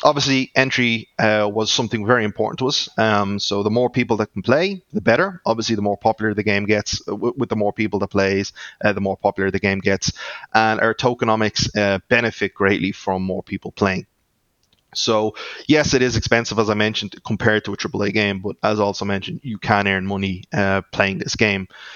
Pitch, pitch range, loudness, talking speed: 110 Hz, 100-115 Hz, -19 LUFS, 210 wpm